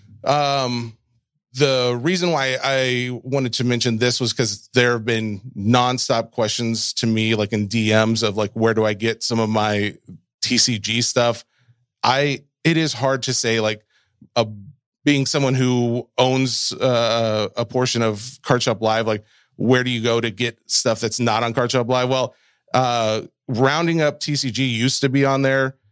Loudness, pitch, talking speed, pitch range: -19 LUFS, 120 Hz, 175 wpm, 115-130 Hz